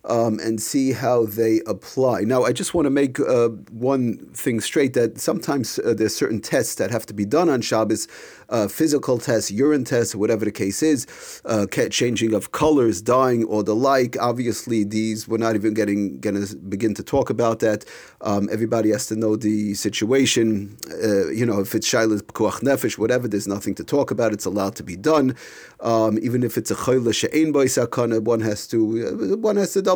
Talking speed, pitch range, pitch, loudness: 200 wpm, 105-130 Hz, 115 Hz, -21 LUFS